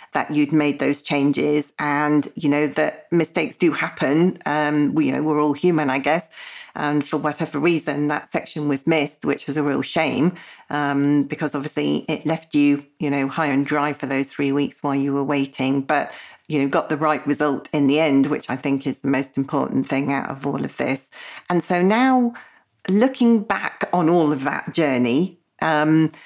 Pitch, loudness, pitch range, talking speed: 150 Hz, -21 LUFS, 140-160 Hz, 200 wpm